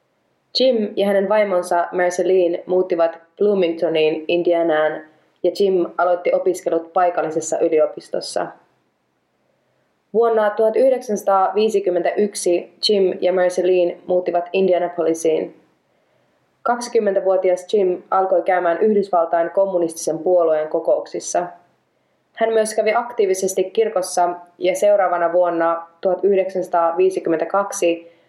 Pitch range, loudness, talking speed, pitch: 170-200 Hz, -18 LUFS, 80 wpm, 180 Hz